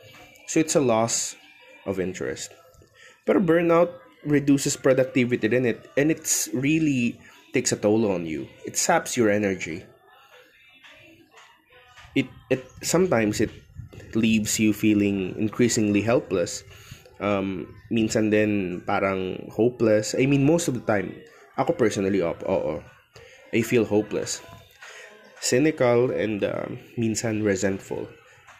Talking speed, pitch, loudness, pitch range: 120 wpm, 115 Hz, -24 LUFS, 105-130 Hz